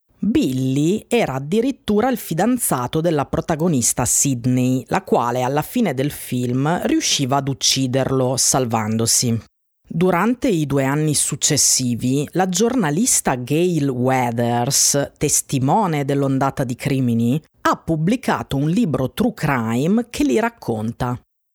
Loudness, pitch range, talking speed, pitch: -18 LUFS, 130-180 Hz, 110 wpm, 140 Hz